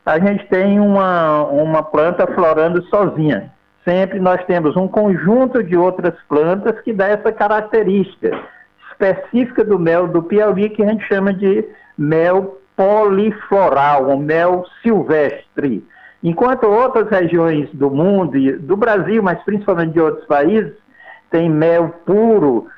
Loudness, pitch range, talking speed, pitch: -15 LUFS, 165-210 Hz, 135 wpm, 190 Hz